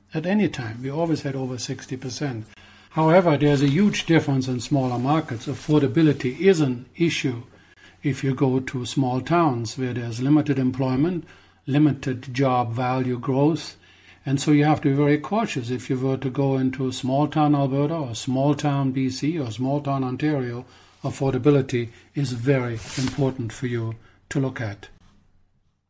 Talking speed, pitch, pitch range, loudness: 165 wpm, 135 Hz, 125-145 Hz, -23 LUFS